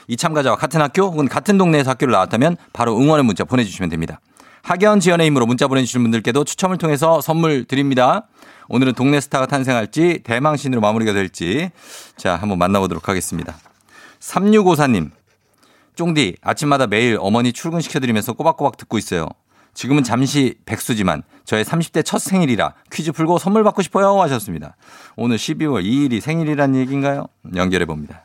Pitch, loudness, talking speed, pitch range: 140 Hz, -17 LUFS, 400 characters per minute, 115-165 Hz